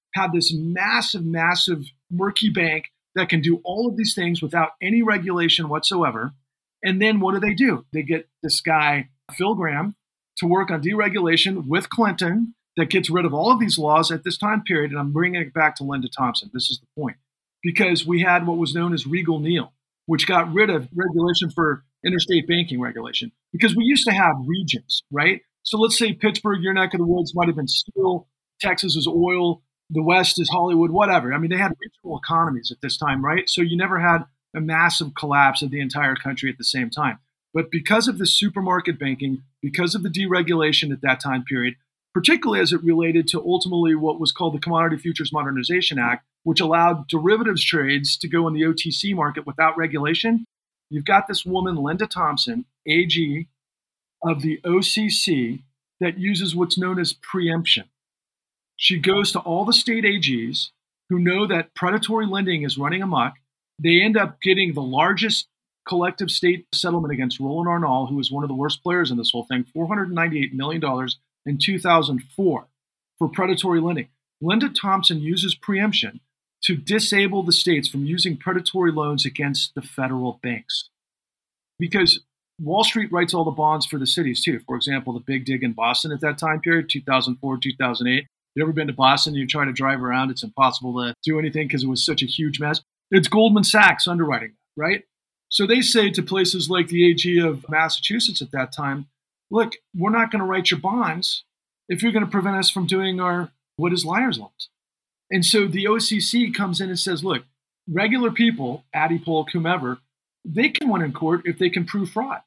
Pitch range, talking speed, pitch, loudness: 140-185 Hz, 190 wpm, 170 Hz, -20 LUFS